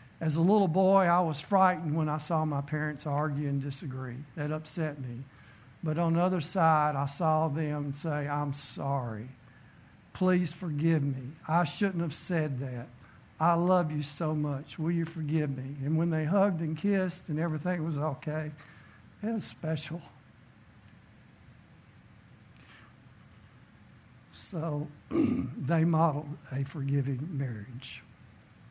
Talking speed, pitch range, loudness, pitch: 135 wpm, 140-165 Hz, -30 LUFS, 155 Hz